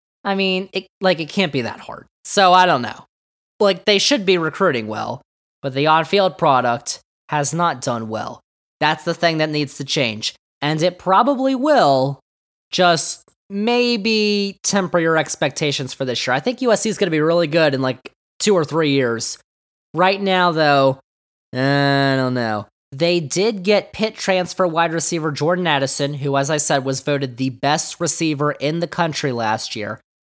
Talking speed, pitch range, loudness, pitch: 180 wpm, 140-185 Hz, -18 LUFS, 160 Hz